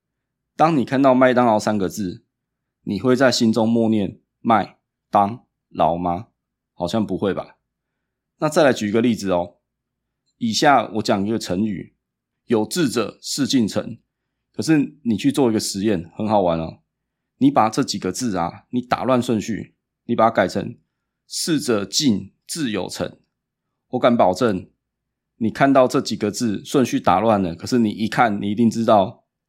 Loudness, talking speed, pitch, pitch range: -20 LUFS, 225 characters per minute, 110 Hz, 100-125 Hz